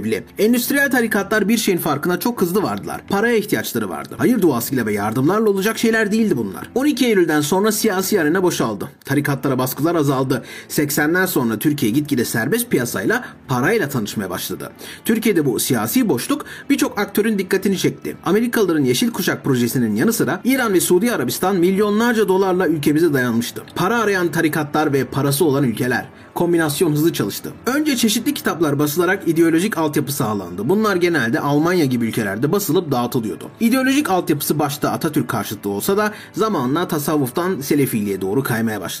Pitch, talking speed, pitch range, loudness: 175 Hz, 150 wpm, 140-215 Hz, -18 LUFS